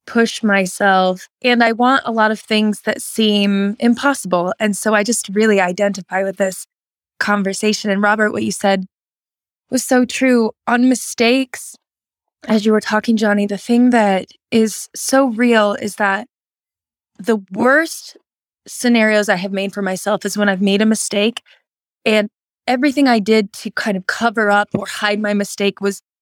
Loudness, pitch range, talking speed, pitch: -16 LUFS, 200-235 Hz, 165 wpm, 215 Hz